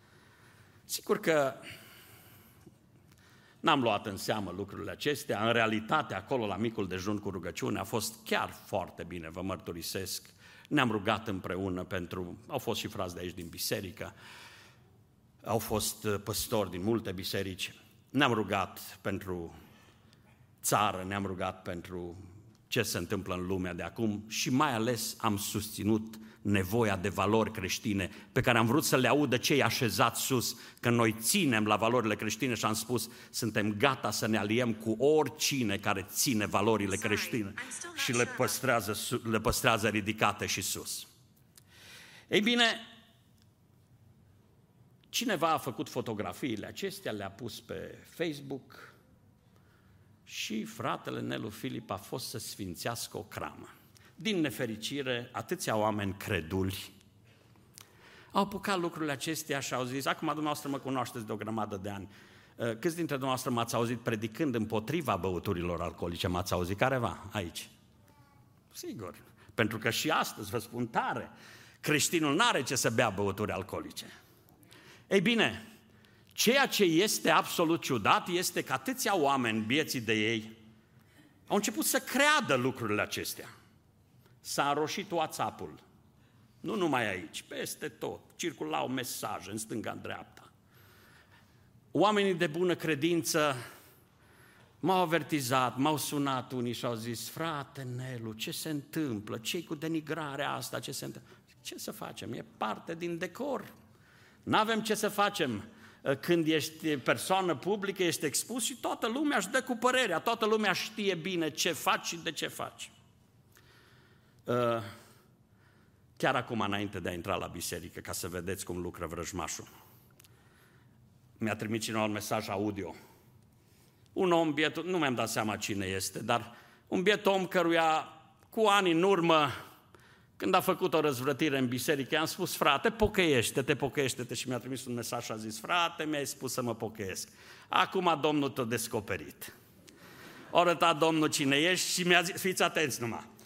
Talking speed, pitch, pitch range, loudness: 145 wpm, 120 Hz, 105-150 Hz, -32 LUFS